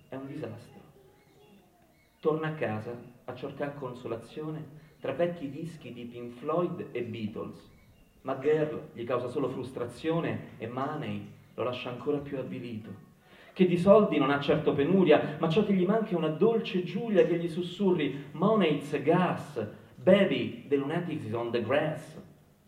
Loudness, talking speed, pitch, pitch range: -29 LUFS, 150 wpm, 150 Hz, 120-170 Hz